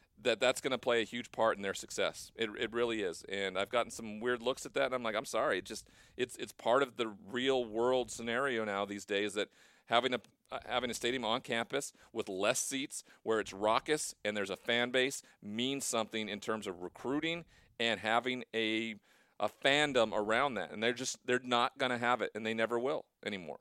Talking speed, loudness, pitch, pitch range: 225 wpm, -35 LUFS, 115 Hz, 110-125 Hz